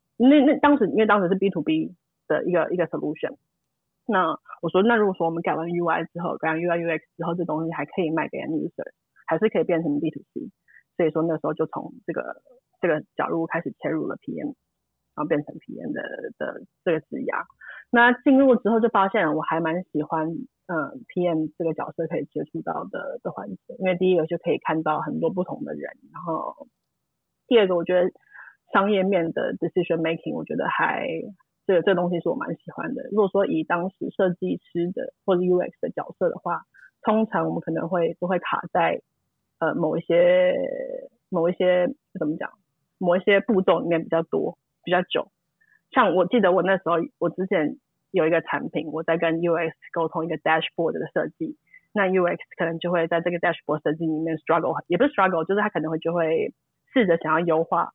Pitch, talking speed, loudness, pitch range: 175 Hz, 355 characters per minute, -24 LUFS, 165-200 Hz